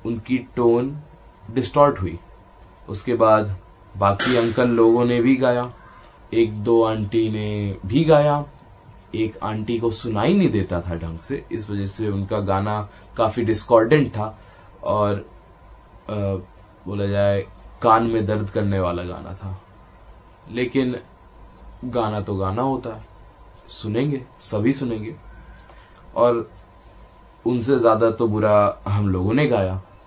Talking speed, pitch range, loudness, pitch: 125 wpm, 100-120 Hz, -21 LUFS, 110 Hz